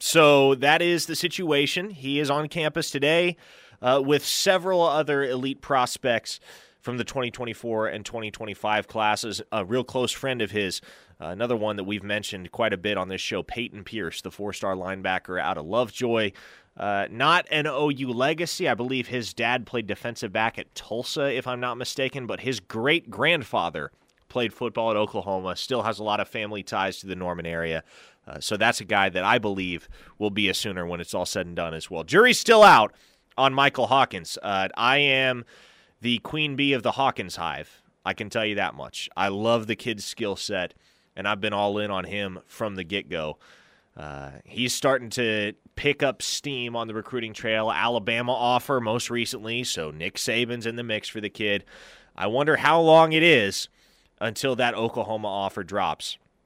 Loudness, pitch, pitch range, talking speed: -24 LUFS, 115 Hz, 100-130 Hz, 190 wpm